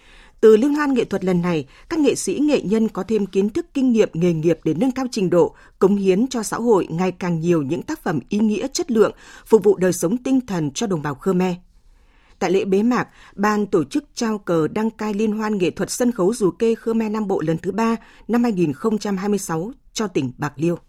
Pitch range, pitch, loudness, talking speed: 180-230 Hz, 210 Hz, -20 LUFS, 235 wpm